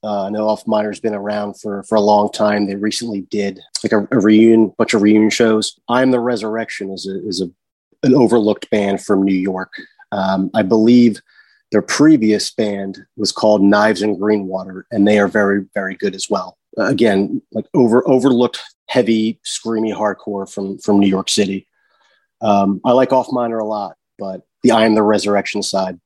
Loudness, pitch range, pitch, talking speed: -16 LUFS, 100-110 Hz, 105 Hz, 190 wpm